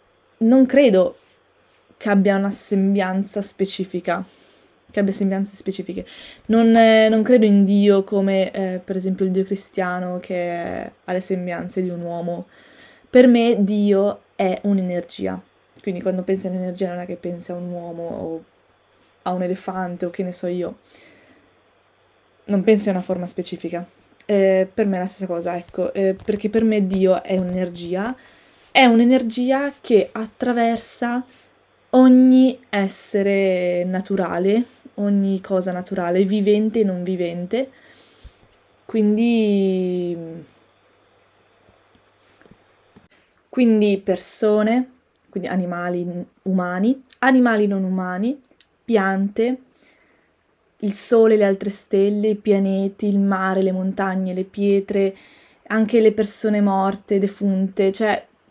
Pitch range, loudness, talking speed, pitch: 185-220 Hz, -19 LUFS, 125 wpm, 195 Hz